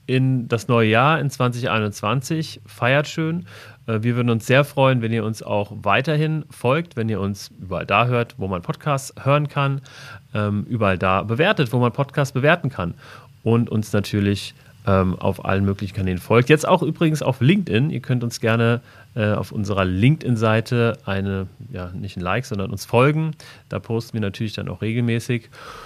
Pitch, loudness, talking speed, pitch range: 120 Hz, -21 LUFS, 170 wpm, 105-135 Hz